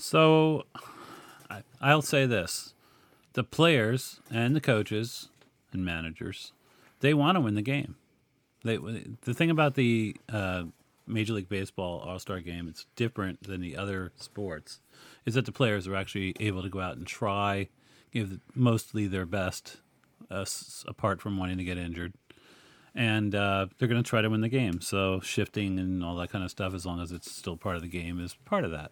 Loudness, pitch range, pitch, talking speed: -30 LUFS, 95-125 Hz, 105 Hz, 195 wpm